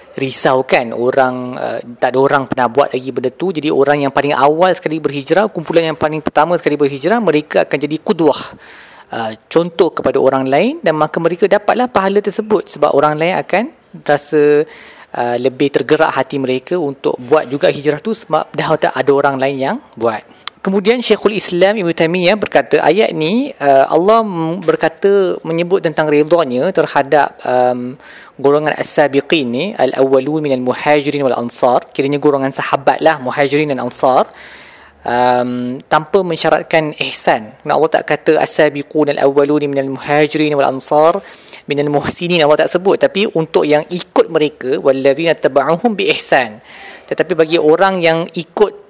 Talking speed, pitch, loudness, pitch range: 155 wpm, 150 Hz, -14 LUFS, 140-170 Hz